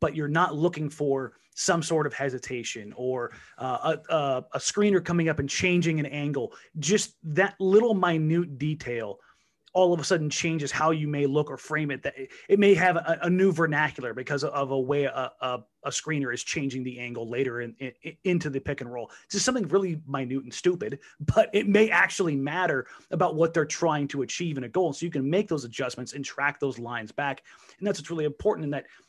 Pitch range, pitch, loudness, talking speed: 135-175 Hz, 150 Hz, -27 LUFS, 215 wpm